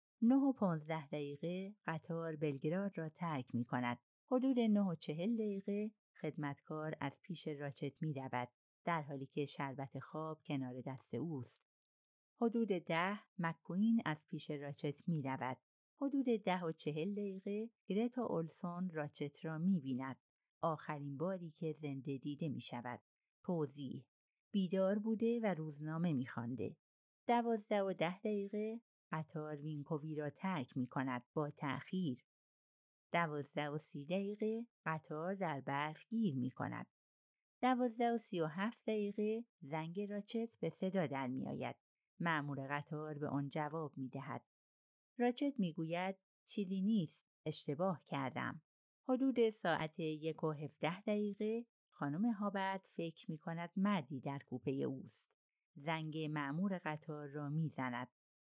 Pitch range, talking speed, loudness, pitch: 145-200 Hz, 130 wpm, -41 LUFS, 160 Hz